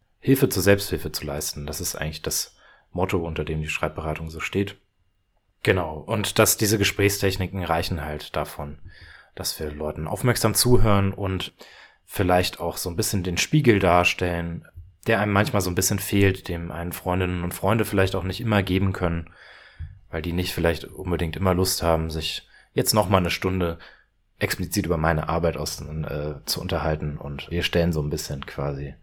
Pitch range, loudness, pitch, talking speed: 80-100 Hz, -24 LUFS, 90 Hz, 175 wpm